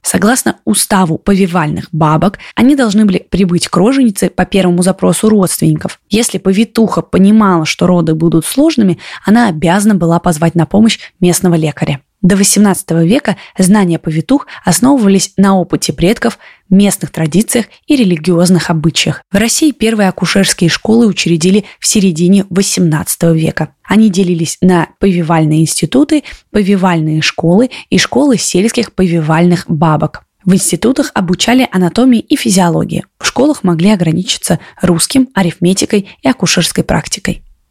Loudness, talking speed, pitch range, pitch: -10 LUFS, 125 wpm, 170-215 Hz, 185 Hz